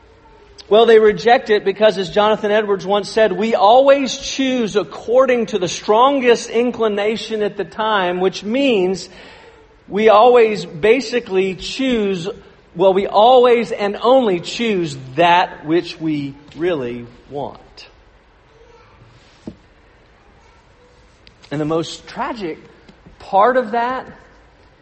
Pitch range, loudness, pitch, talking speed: 180-235 Hz, -15 LUFS, 210 Hz, 110 wpm